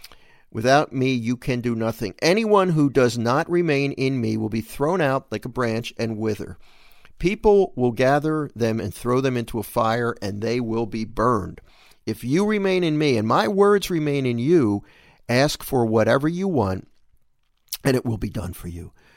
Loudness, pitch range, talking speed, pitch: -22 LUFS, 110-145 Hz, 190 wpm, 125 Hz